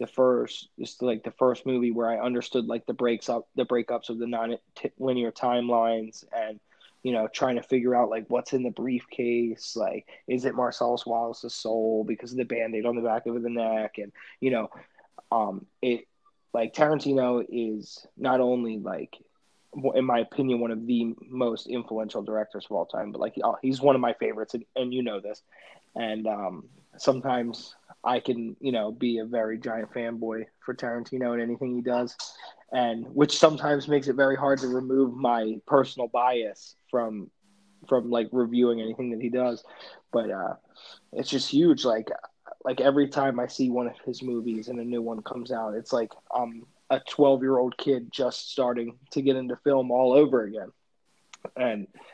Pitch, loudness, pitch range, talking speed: 120 Hz, -27 LUFS, 115-130 Hz, 180 wpm